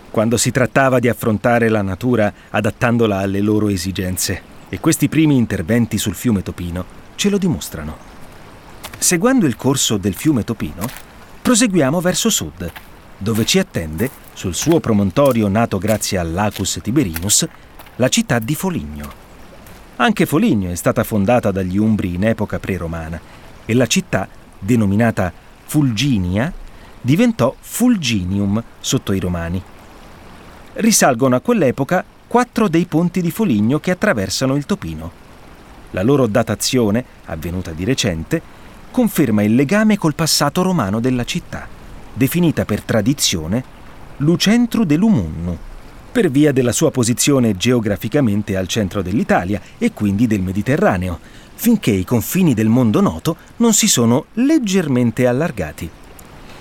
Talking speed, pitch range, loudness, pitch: 125 wpm, 100-150 Hz, -17 LUFS, 115 Hz